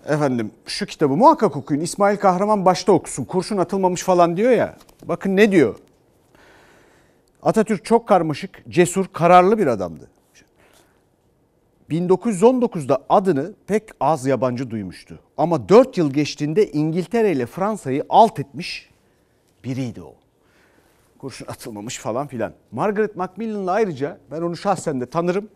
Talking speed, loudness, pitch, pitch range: 125 wpm, -19 LUFS, 170 Hz, 135-200 Hz